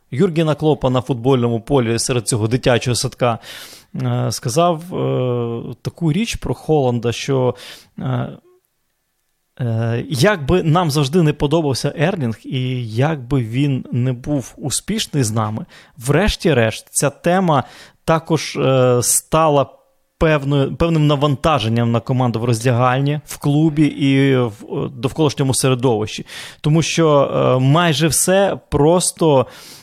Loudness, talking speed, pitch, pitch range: -17 LUFS, 110 wpm, 135 Hz, 125-155 Hz